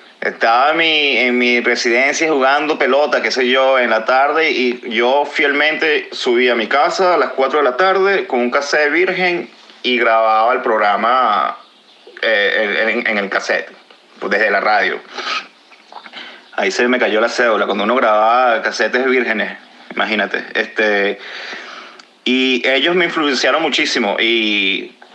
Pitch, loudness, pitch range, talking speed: 130 Hz, -14 LUFS, 120-155 Hz, 150 wpm